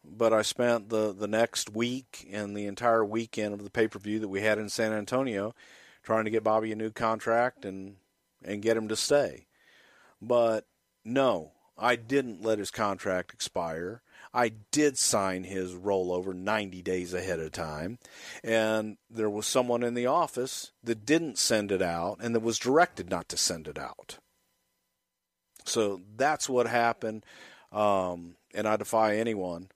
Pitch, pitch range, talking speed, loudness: 110 Hz, 100-115 Hz, 165 wpm, -29 LUFS